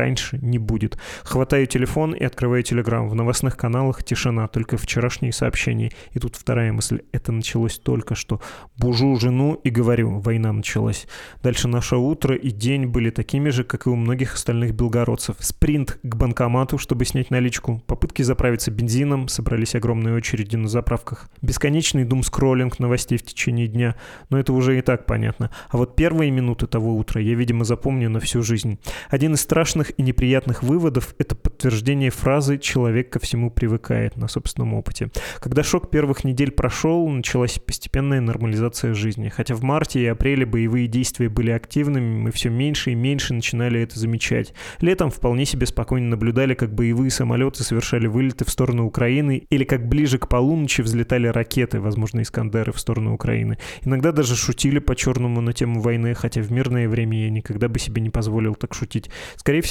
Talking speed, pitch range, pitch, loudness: 170 wpm, 115-130 Hz, 120 Hz, -21 LUFS